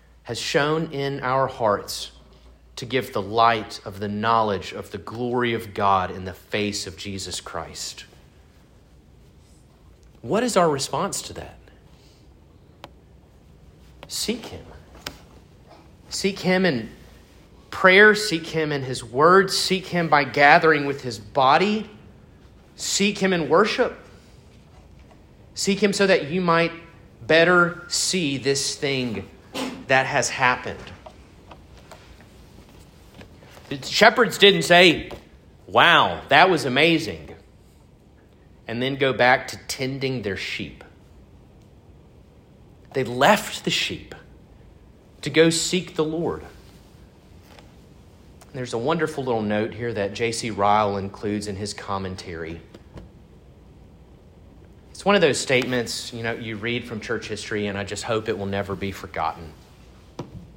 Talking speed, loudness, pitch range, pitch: 125 wpm, -21 LUFS, 95-150 Hz, 115 Hz